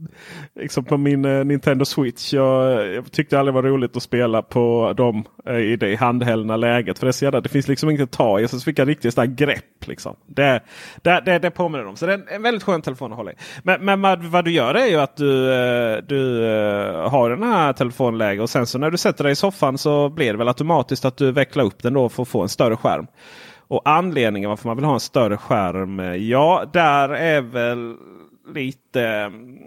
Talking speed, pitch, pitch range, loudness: 220 wpm, 135 Hz, 120-150 Hz, -19 LUFS